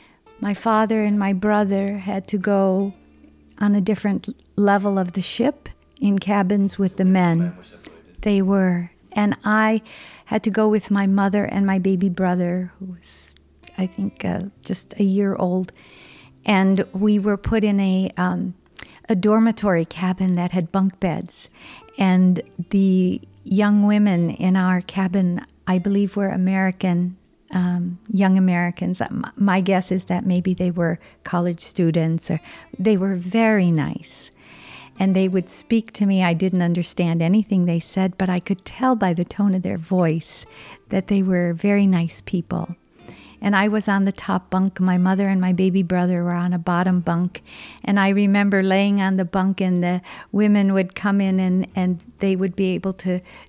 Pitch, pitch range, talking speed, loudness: 190 Hz, 180-200 Hz, 170 wpm, -20 LUFS